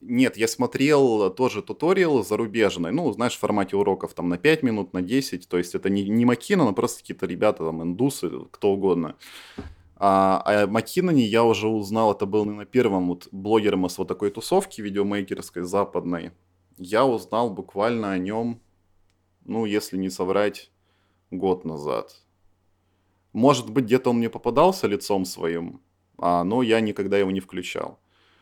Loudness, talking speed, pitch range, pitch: -23 LUFS, 155 wpm, 90-115 Hz, 100 Hz